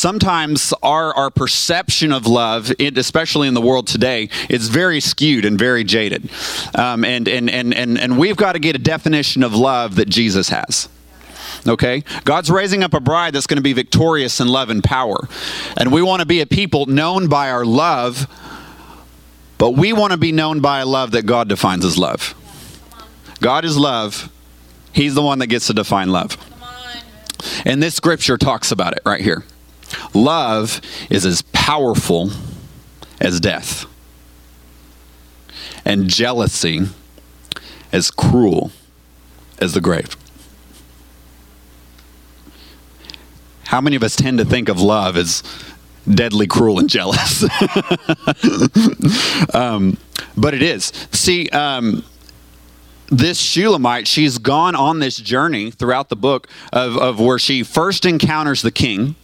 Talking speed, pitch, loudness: 145 wpm, 120 Hz, -15 LUFS